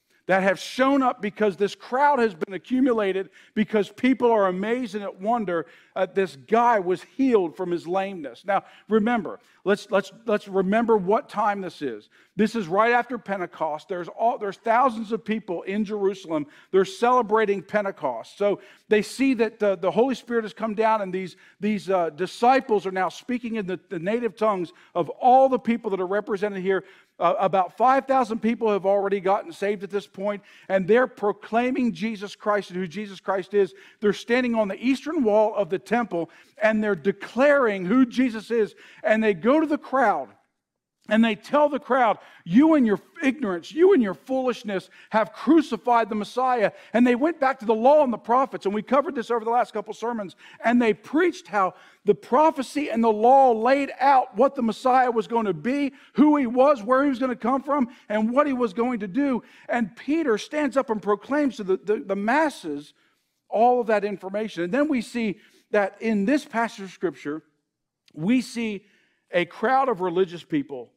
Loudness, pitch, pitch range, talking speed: -23 LUFS, 220 Hz, 195-250 Hz, 195 wpm